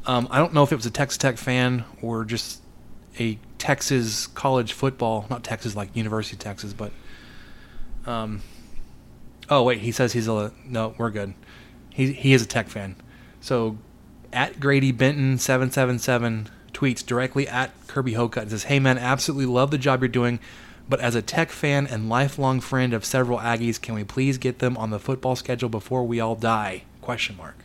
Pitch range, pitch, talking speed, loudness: 110-130 Hz, 120 Hz, 180 wpm, -24 LUFS